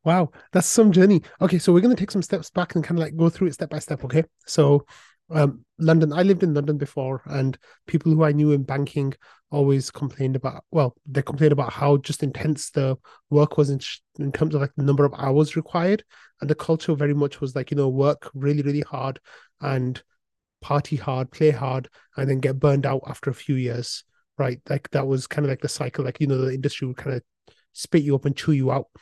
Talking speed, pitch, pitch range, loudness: 235 wpm, 145 Hz, 135-155 Hz, -23 LUFS